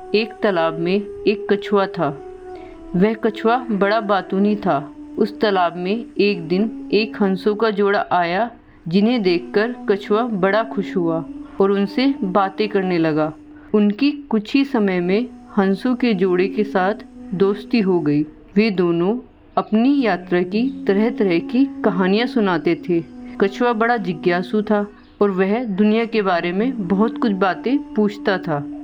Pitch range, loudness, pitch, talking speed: 190-235 Hz, -19 LUFS, 210 Hz, 150 wpm